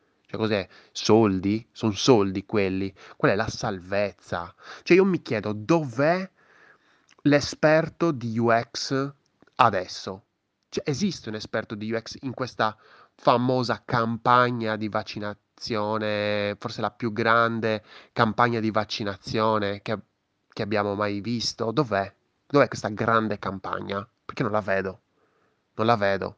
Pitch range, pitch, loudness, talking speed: 105-120 Hz, 110 Hz, -25 LUFS, 125 wpm